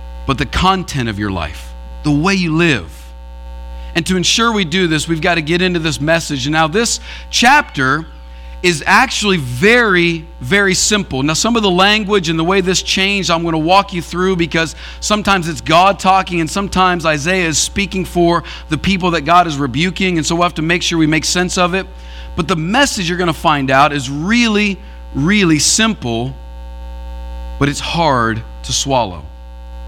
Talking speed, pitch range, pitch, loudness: 190 wpm, 120-190 Hz, 170 Hz, -14 LUFS